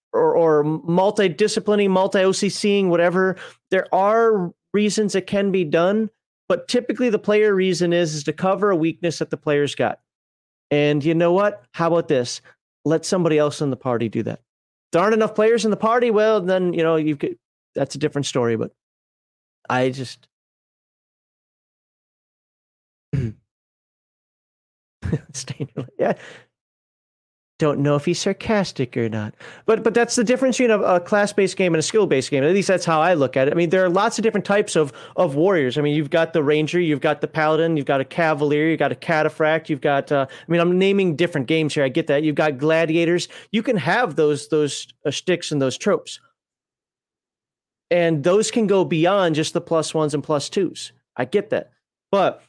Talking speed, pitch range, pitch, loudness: 190 wpm, 150-195 Hz, 170 Hz, -20 LUFS